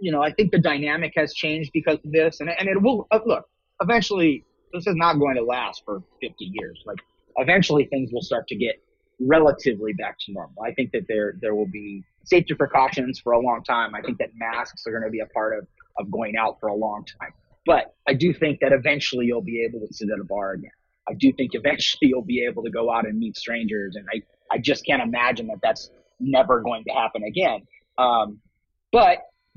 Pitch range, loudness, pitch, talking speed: 120-170 Hz, -22 LUFS, 145 Hz, 225 wpm